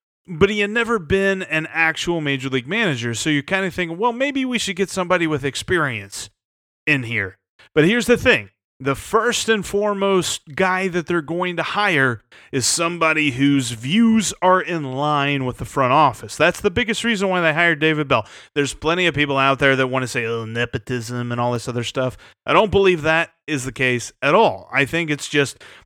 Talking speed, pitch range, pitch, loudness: 205 wpm, 135-190 Hz, 160 Hz, -19 LUFS